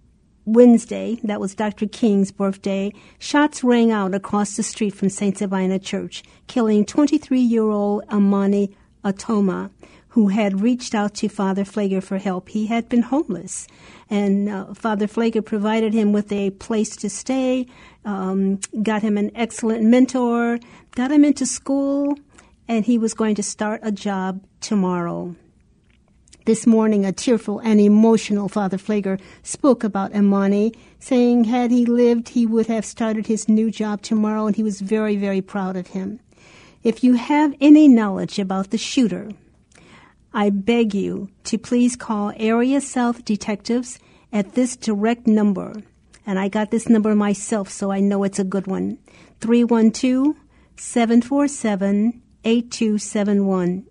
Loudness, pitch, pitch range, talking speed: -20 LUFS, 215 Hz, 200-235 Hz, 145 wpm